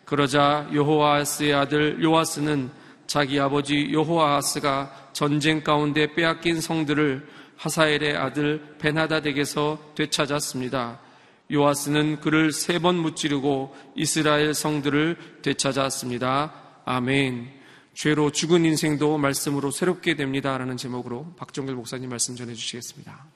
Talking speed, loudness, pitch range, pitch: 305 characters per minute, -23 LUFS, 135-155 Hz, 150 Hz